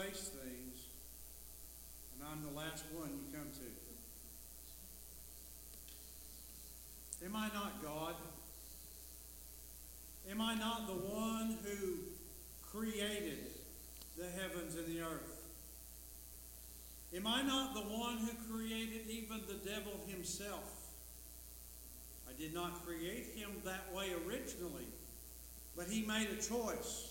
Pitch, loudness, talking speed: 155 Hz, -46 LUFS, 110 wpm